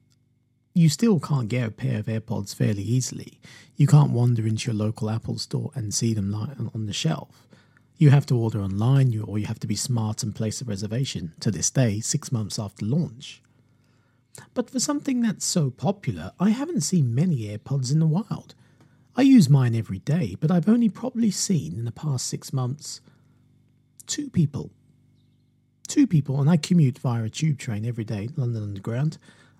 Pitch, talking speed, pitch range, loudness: 130 Hz, 180 wpm, 115-155 Hz, -24 LUFS